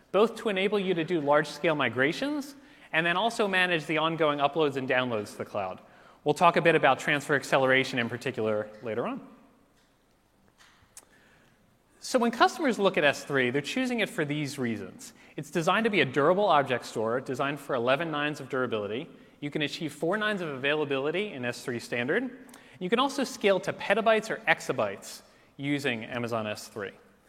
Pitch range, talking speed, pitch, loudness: 135-210 Hz, 175 wpm, 155 Hz, -27 LUFS